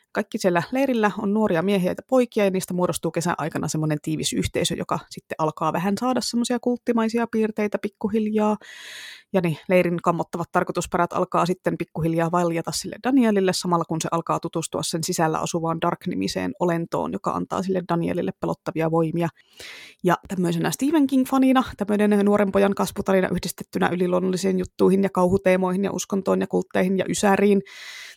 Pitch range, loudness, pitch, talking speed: 170-205 Hz, -23 LUFS, 185 Hz, 150 wpm